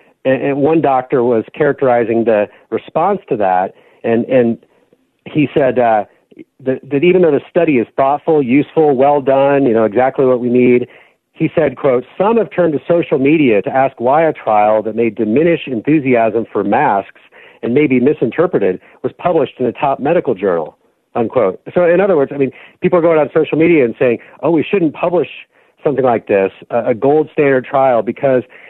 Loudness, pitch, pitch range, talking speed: -14 LUFS, 135 Hz, 120-155 Hz, 185 wpm